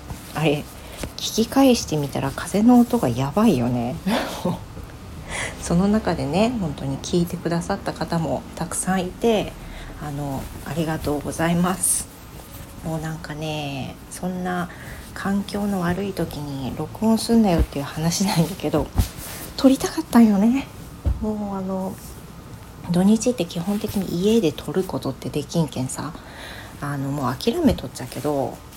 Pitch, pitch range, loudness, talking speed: 170 Hz, 145-205 Hz, -22 LUFS, 285 characters per minute